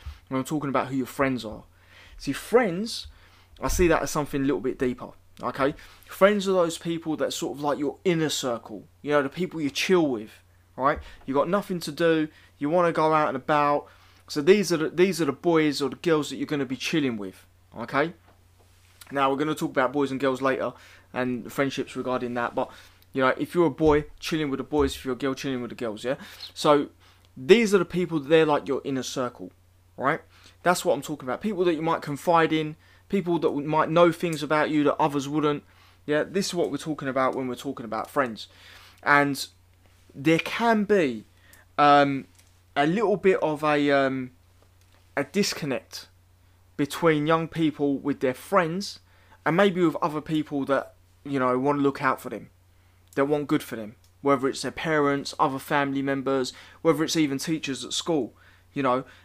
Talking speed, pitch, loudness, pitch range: 205 wpm, 140 Hz, -25 LUFS, 110-155 Hz